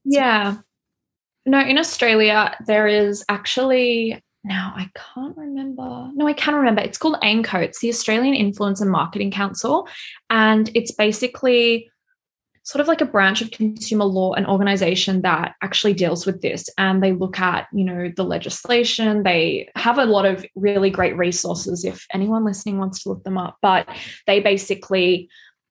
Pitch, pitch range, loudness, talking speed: 210 Hz, 190-235 Hz, -19 LUFS, 165 wpm